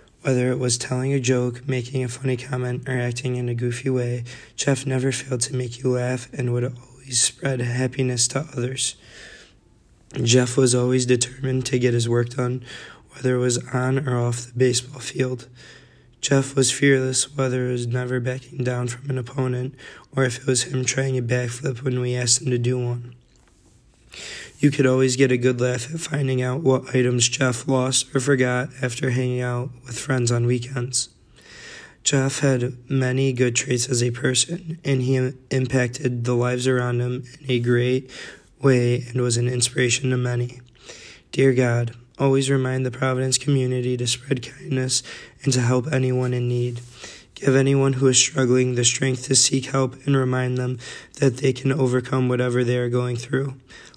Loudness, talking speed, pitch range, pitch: -22 LUFS, 180 wpm, 125-130 Hz, 125 Hz